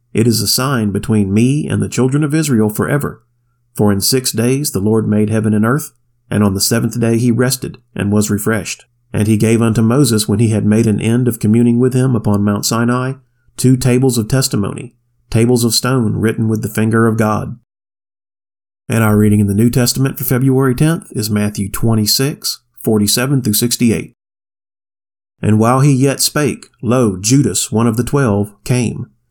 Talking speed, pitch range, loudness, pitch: 180 wpm, 105-125 Hz, -14 LUFS, 115 Hz